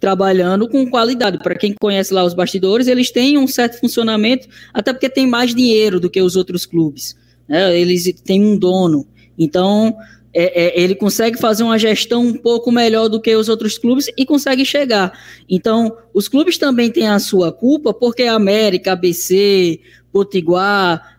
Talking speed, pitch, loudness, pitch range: 170 wpm, 210 Hz, -14 LUFS, 185-235 Hz